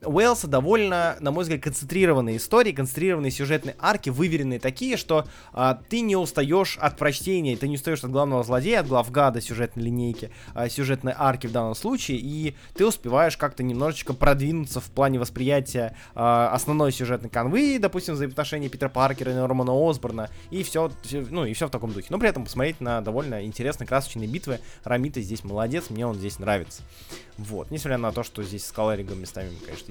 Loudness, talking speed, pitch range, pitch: -25 LUFS, 185 wpm, 120-155 Hz, 130 Hz